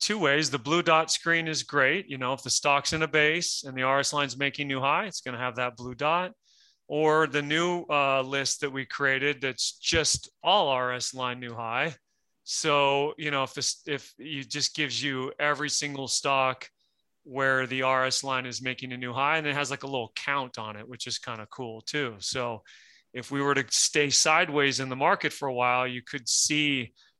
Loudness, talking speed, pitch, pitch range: -26 LUFS, 215 wpm, 140 Hz, 130-150 Hz